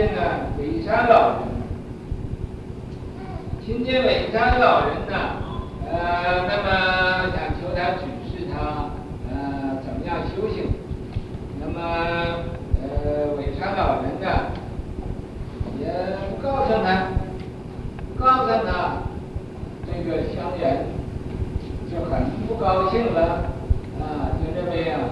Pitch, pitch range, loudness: 170 Hz, 150-185 Hz, -24 LUFS